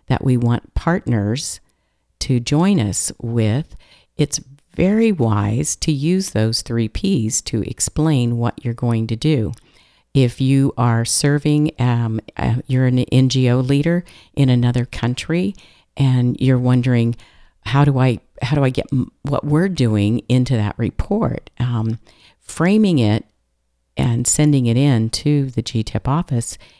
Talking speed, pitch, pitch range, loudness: 145 wpm, 125 Hz, 115-140 Hz, -18 LUFS